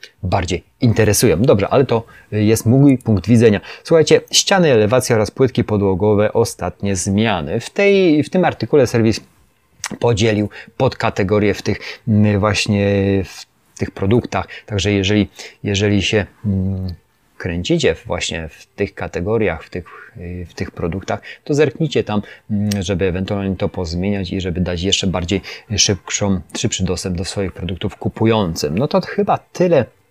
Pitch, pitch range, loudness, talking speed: 105 Hz, 95-115 Hz, -17 LUFS, 135 wpm